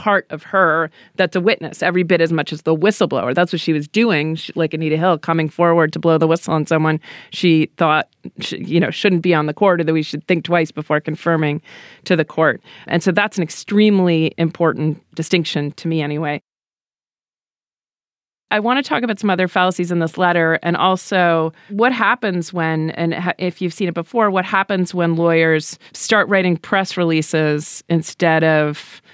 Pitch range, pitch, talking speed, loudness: 160-185 Hz, 170 Hz, 190 wpm, -17 LUFS